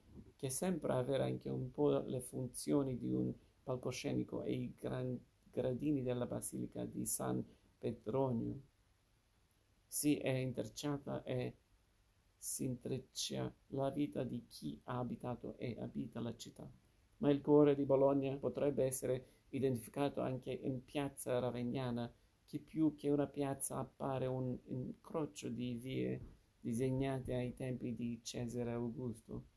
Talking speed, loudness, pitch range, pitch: 130 wpm, -40 LUFS, 105-135 Hz, 125 Hz